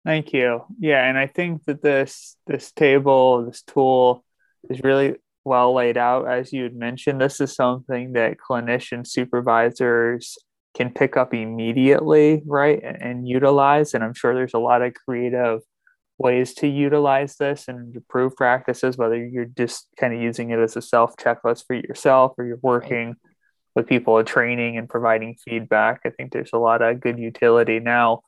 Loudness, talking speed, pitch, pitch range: -20 LUFS, 170 wpm, 125 Hz, 120-135 Hz